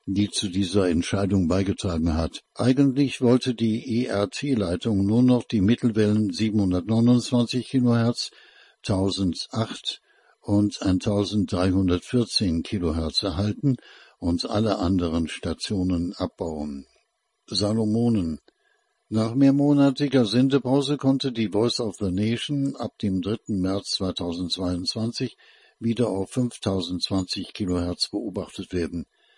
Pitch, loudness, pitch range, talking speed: 105 Hz, -24 LUFS, 95-120 Hz, 95 wpm